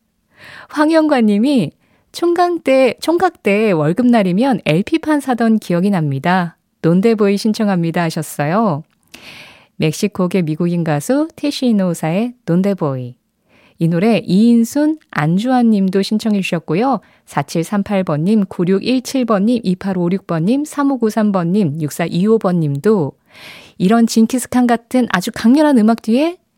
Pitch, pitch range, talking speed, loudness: 210 Hz, 175-245 Hz, 235 characters per minute, -15 LUFS